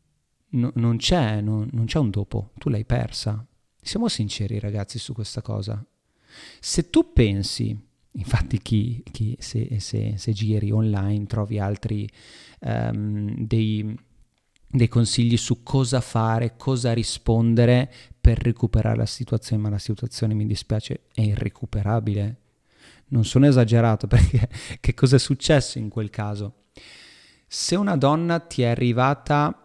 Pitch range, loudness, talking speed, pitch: 105-125 Hz, -23 LUFS, 135 wpm, 115 Hz